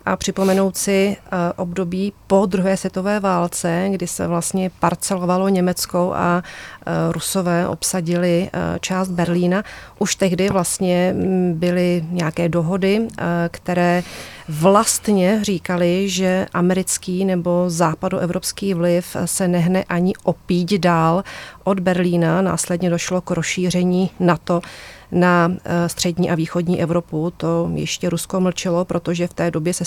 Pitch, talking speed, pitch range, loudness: 180 Hz, 115 wpm, 175-190 Hz, -19 LUFS